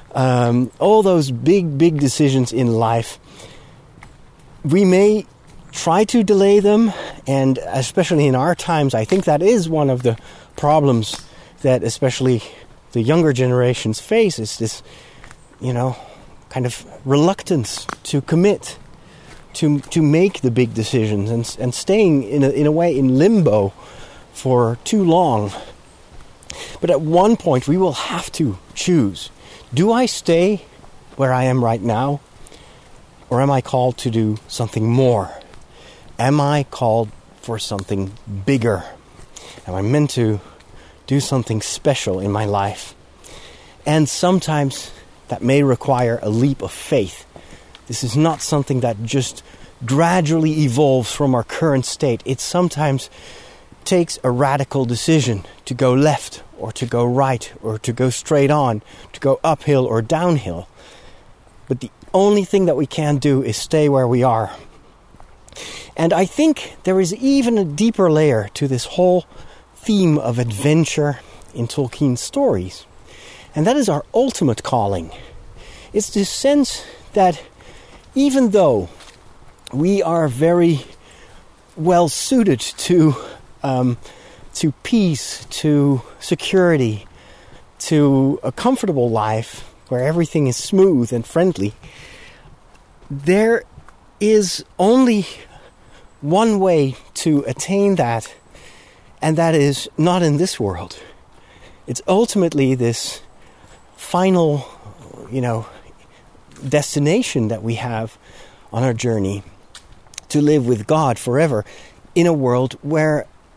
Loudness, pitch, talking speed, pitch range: -17 LUFS, 140 Hz, 130 wpm, 120-165 Hz